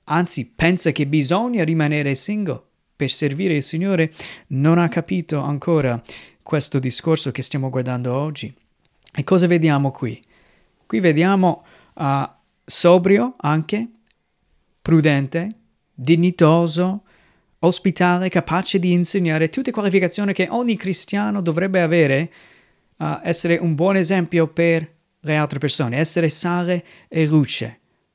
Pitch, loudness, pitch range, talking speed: 165 Hz, -19 LUFS, 150-180 Hz, 120 wpm